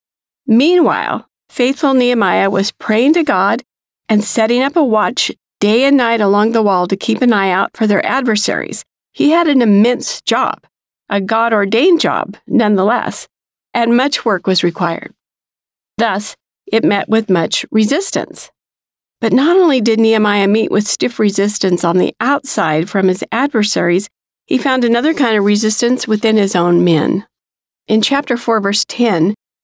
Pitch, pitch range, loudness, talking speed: 225 Hz, 200-250 Hz, -13 LUFS, 155 wpm